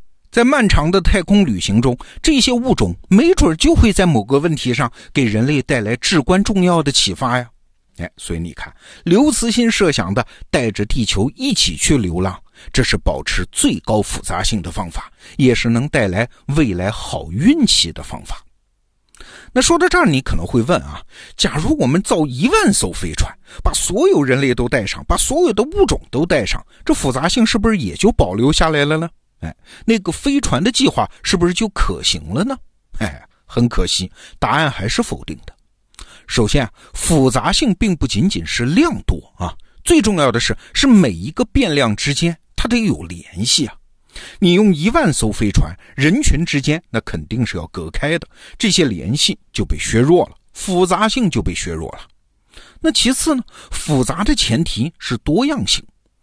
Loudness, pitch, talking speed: -16 LUFS, 145 Hz, 260 characters per minute